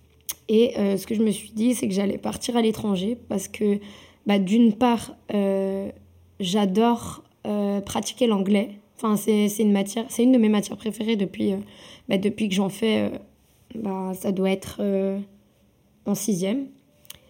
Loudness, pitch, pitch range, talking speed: -24 LUFS, 205 Hz, 195-225 Hz, 175 wpm